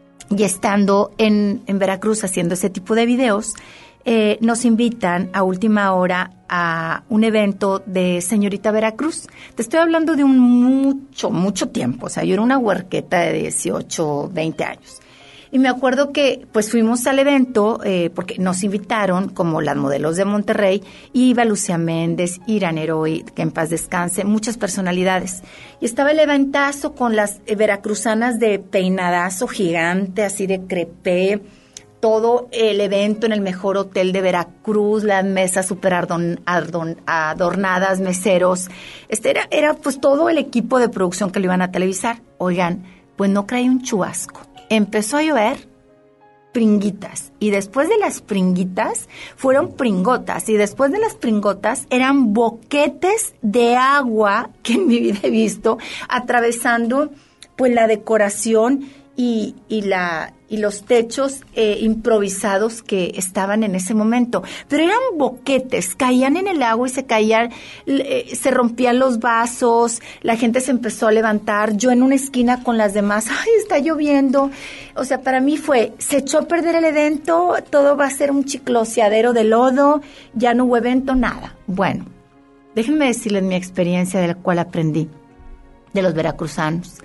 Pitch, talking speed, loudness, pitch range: 220 Hz, 155 wpm, -18 LUFS, 190-255 Hz